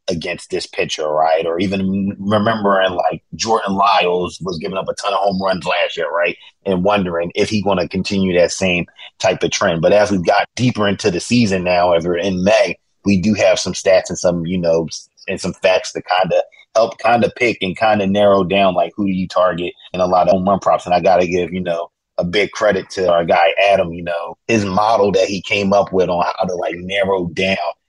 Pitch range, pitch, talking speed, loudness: 90-100 Hz, 95 Hz, 240 wpm, -16 LUFS